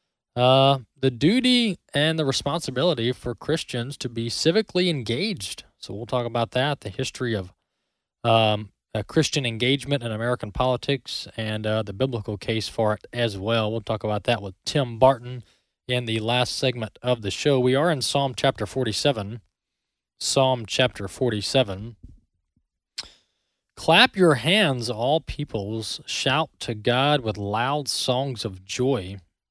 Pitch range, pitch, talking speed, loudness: 110-140 Hz, 125 Hz, 145 wpm, -23 LUFS